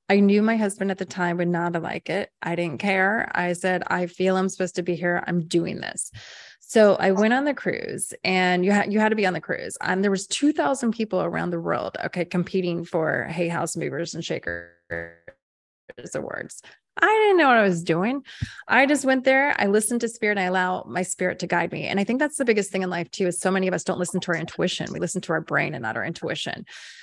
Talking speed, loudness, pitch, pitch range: 250 wpm, -23 LUFS, 185 Hz, 175-210 Hz